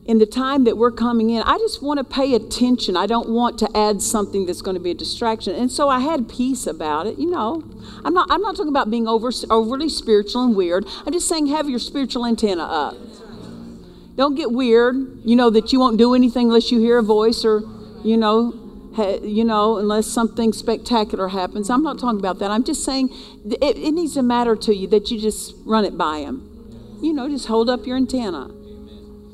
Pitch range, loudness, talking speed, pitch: 215-260 Hz, -19 LUFS, 220 wpm, 230 Hz